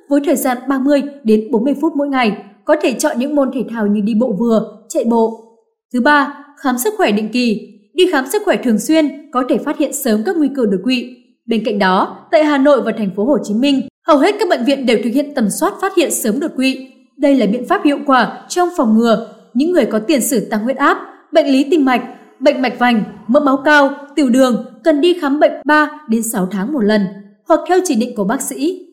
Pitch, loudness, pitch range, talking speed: 265 Hz, -15 LUFS, 225-300 Hz, 245 wpm